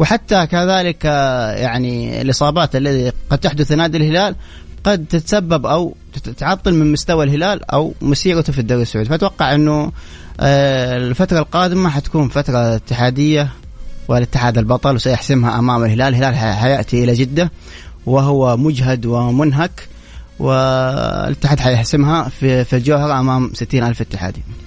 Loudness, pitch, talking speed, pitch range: -15 LUFS, 135 Hz, 115 wpm, 120-155 Hz